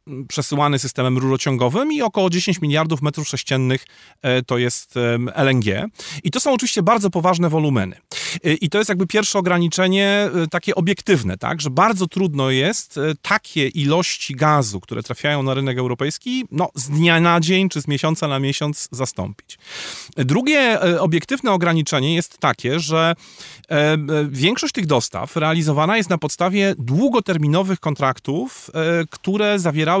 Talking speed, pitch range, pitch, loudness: 135 wpm, 135-185 Hz, 155 Hz, -19 LUFS